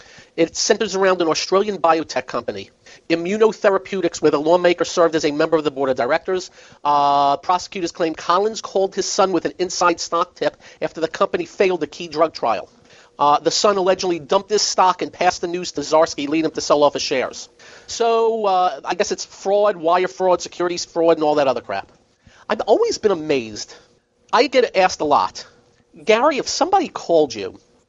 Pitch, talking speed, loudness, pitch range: 175 Hz, 190 wpm, -19 LUFS, 160-195 Hz